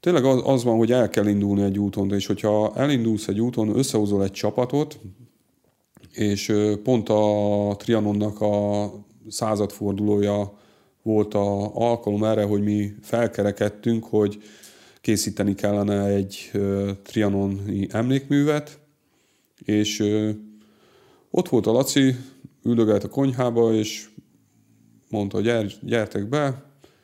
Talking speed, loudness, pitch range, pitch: 110 wpm, -23 LUFS, 100-120 Hz, 105 Hz